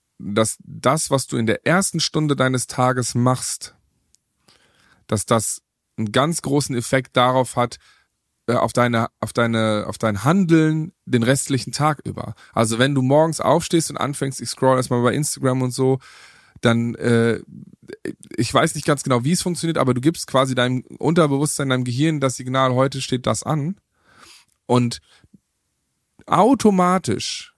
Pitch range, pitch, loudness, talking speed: 120-155 Hz, 130 Hz, -20 LUFS, 155 wpm